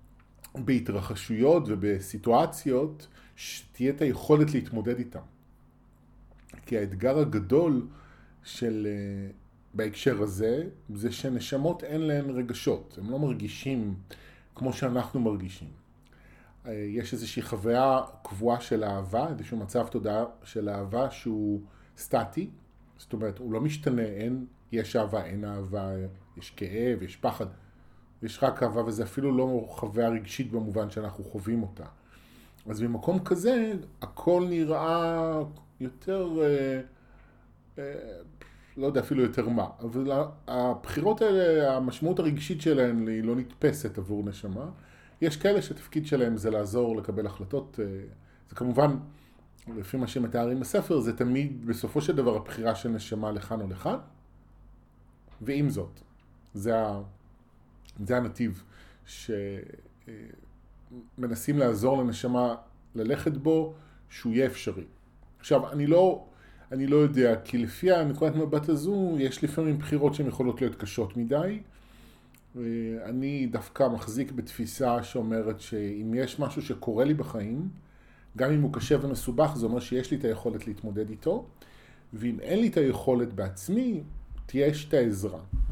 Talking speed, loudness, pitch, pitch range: 125 wpm, -29 LUFS, 120 Hz, 105-135 Hz